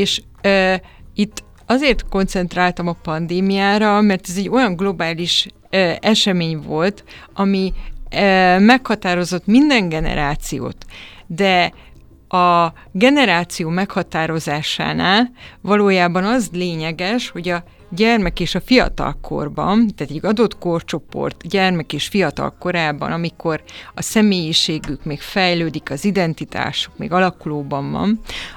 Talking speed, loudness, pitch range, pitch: 110 wpm, -17 LUFS, 165-200 Hz, 180 Hz